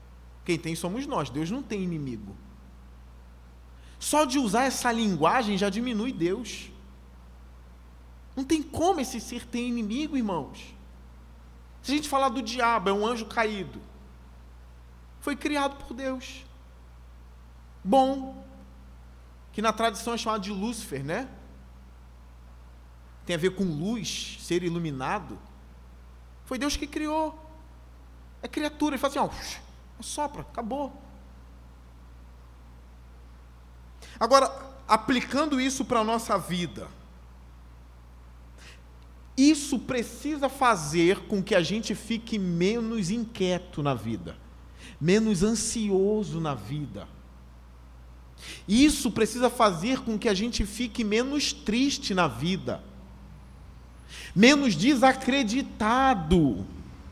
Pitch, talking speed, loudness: 170 Hz, 110 wpm, -27 LUFS